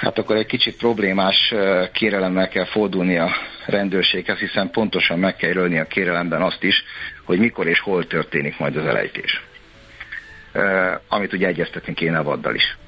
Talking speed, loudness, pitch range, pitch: 160 wpm, -19 LUFS, 90-105 Hz, 95 Hz